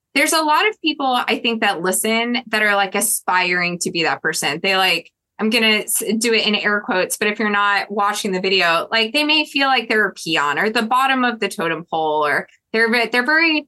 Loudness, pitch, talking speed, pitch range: -17 LUFS, 210 Hz, 230 wpm, 190-245 Hz